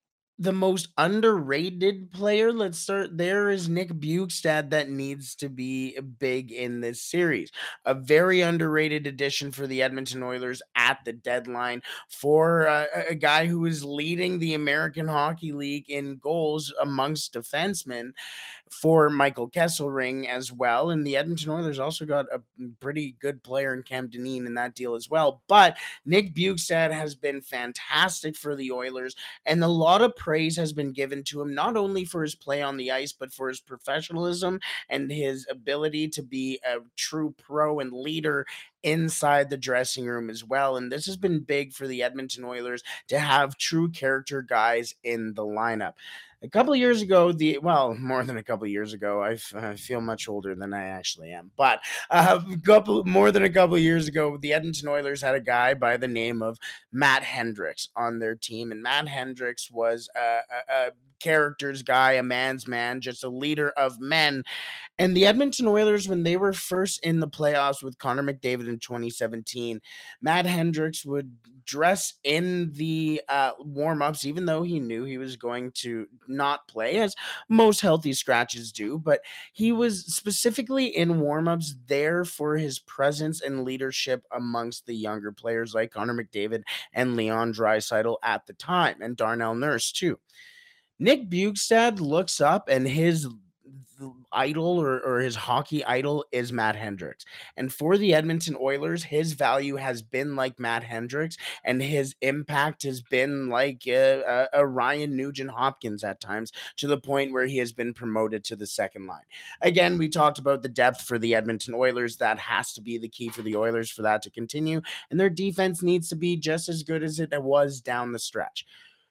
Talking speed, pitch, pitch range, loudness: 180 wpm, 140 Hz, 125-160 Hz, -26 LUFS